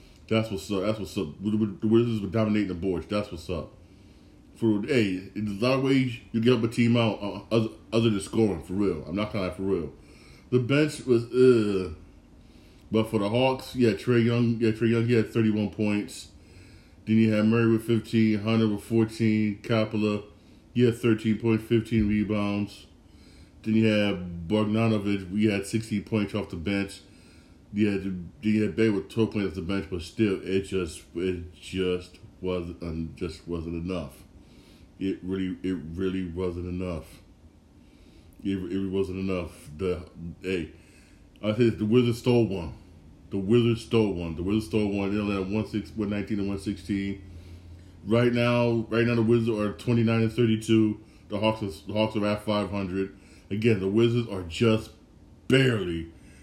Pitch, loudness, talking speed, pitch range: 105 Hz, -26 LUFS, 175 wpm, 90-110 Hz